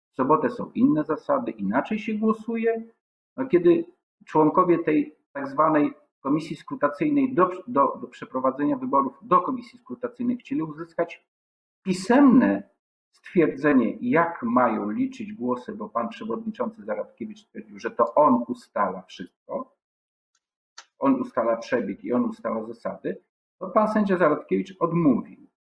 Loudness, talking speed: -24 LUFS, 125 wpm